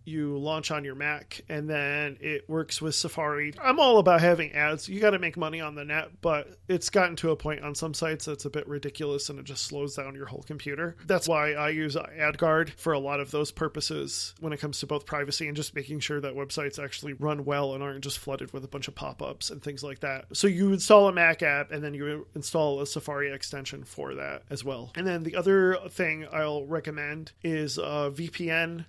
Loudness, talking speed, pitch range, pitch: -28 LUFS, 235 wpm, 145-160 Hz, 150 Hz